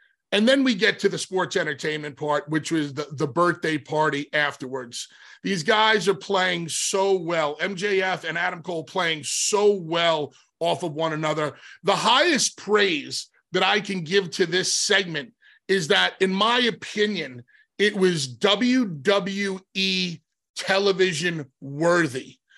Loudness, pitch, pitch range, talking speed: -23 LUFS, 185 Hz, 155-200 Hz, 140 wpm